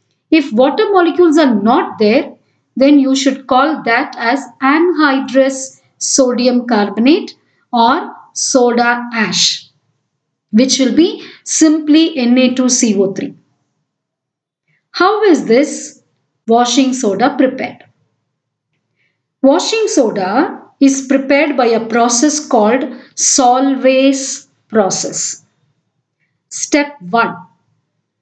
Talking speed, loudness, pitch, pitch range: 85 wpm, -12 LUFS, 255 Hz, 220-280 Hz